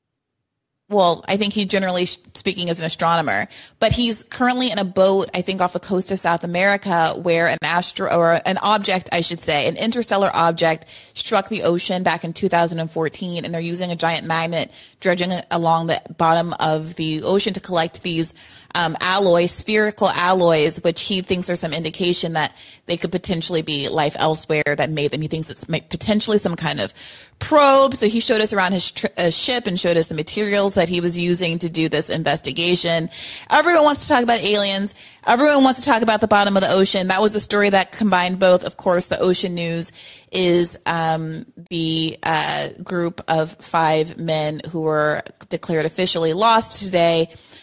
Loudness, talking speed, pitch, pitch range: -19 LUFS, 190 wpm, 175 Hz, 165-195 Hz